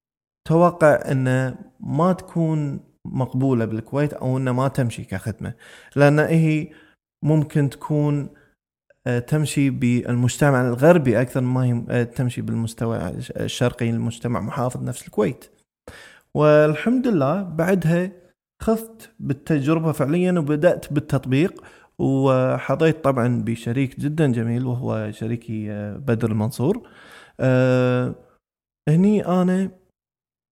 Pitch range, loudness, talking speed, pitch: 120-160 Hz, -21 LUFS, 90 wpm, 135 Hz